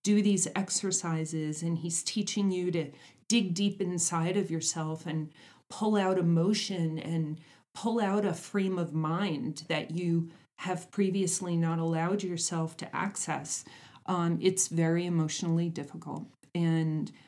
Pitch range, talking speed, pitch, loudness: 165-190 Hz, 135 wpm, 170 Hz, -31 LUFS